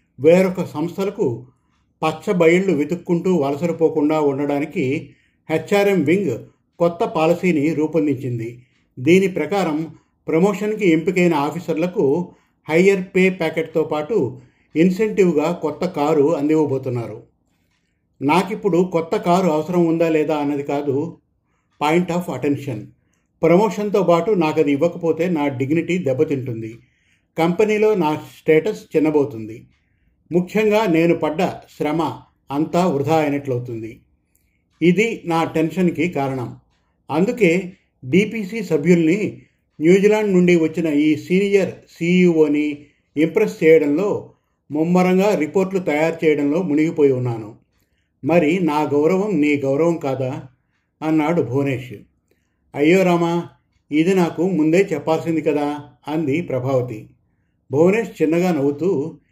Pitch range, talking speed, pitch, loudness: 145-175 Hz, 95 wpm, 160 Hz, -18 LUFS